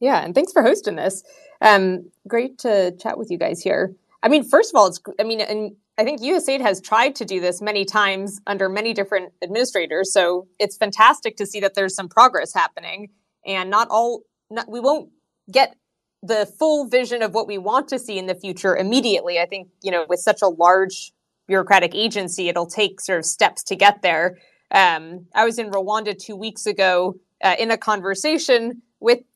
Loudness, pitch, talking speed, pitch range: -19 LUFS, 205 Hz, 200 wpm, 190-225 Hz